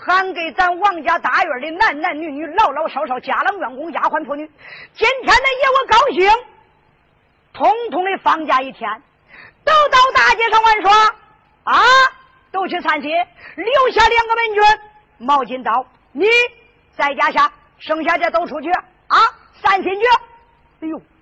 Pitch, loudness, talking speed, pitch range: 365 Hz, -15 LUFS, 225 characters per minute, 305-440 Hz